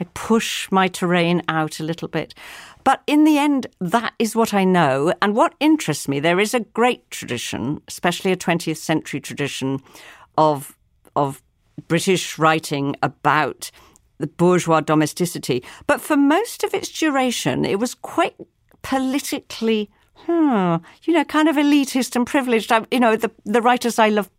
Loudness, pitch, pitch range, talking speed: -20 LUFS, 210 Hz, 160-265 Hz, 160 wpm